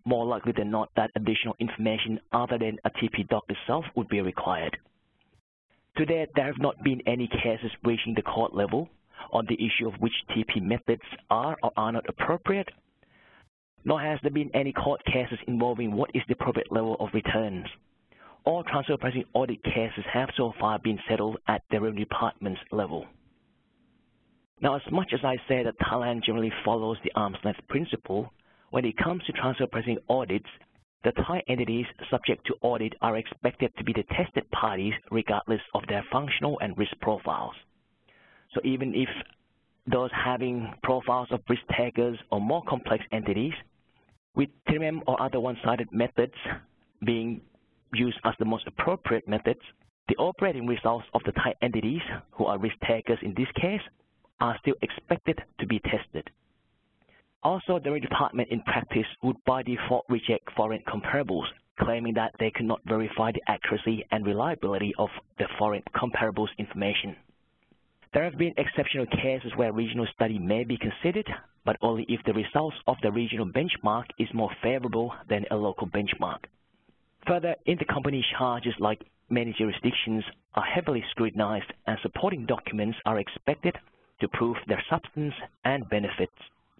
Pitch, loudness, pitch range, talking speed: 115 Hz, -29 LUFS, 110-130 Hz, 160 wpm